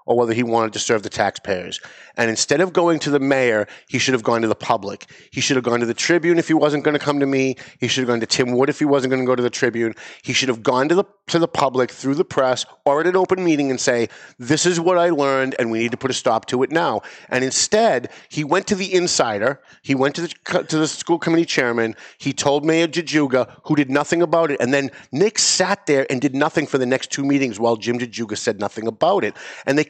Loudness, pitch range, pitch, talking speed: -19 LUFS, 125-165 Hz, 140 Hz, 270 wpm